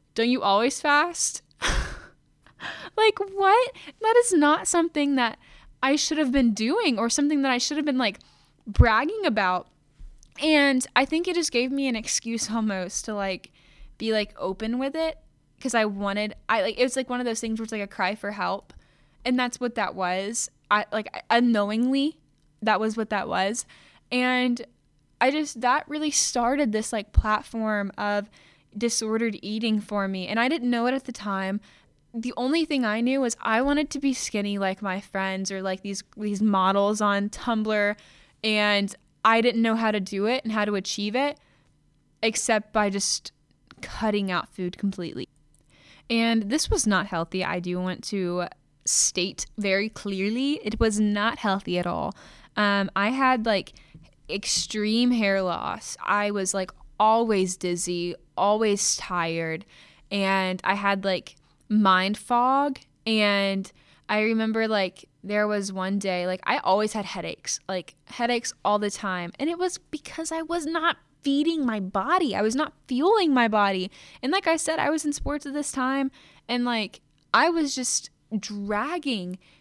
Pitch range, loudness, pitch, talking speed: 195-255 Hz, -25 LUFS, 220 Hz, 170 wpm